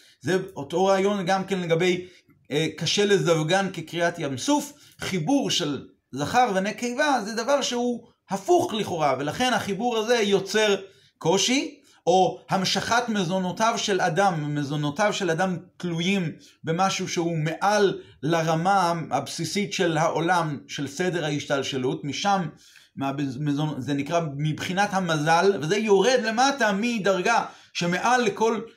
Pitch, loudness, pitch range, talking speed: 190 Hz, -24 LUFS, 160-210 Hz, 120 wpm